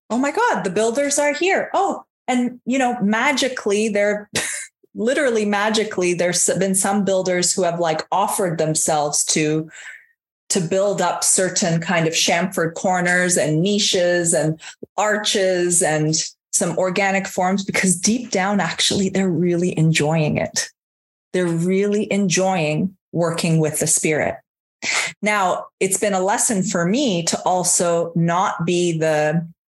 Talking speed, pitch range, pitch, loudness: 135 wpm, 170-205 Hz, 185 Hz, -19 LUFS